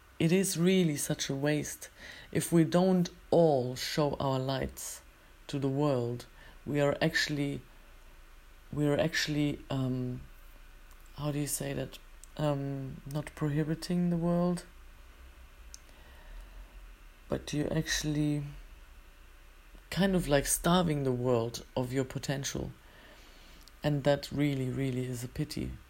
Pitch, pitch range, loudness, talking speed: 140 Hz, 120-150 Hz, -31 LUFS, 120 wpm